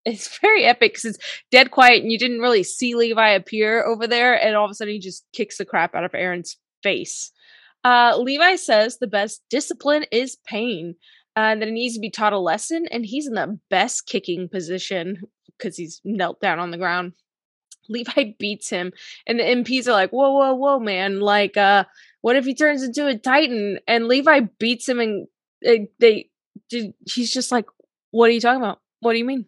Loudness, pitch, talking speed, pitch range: -19 LUFS, 230 Hz, 210 wpm, 205-255 Hz